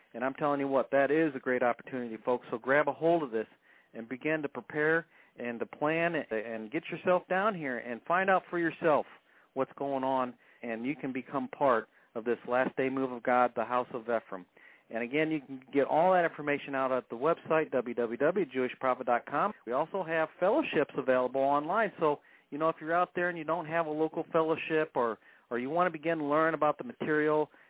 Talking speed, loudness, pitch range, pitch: 210 wpm, -31 LUFS, 125-160 Hz, 145 Hz